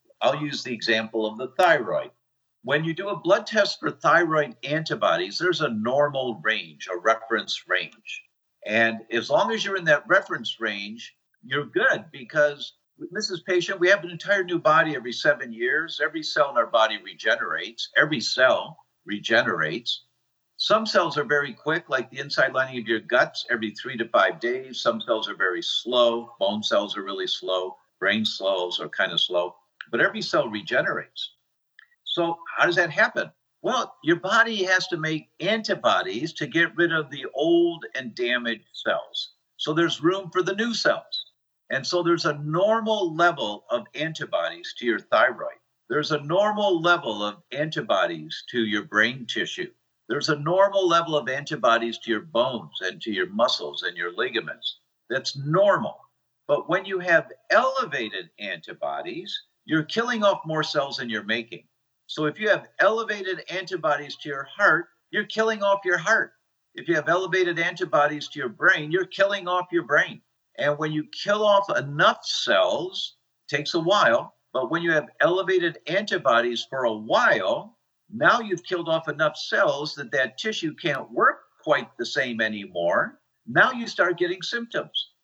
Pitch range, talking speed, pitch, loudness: 130-200 Hz, 170 wpm, 165 Hz, -24 LUFS